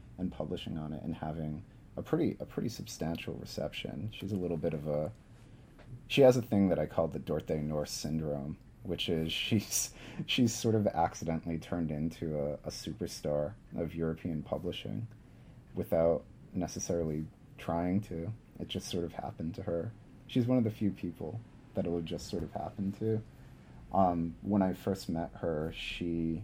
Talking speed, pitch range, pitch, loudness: 175 wpm, 80-110 Hz, 85 Hz, -34 LUFS